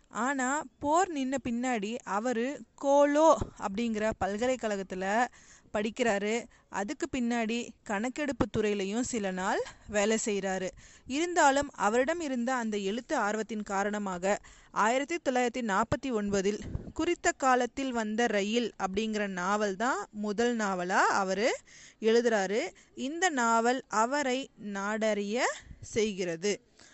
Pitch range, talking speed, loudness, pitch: 205-260 Hz, 100 wpm, -30 LUFS, 230 Hz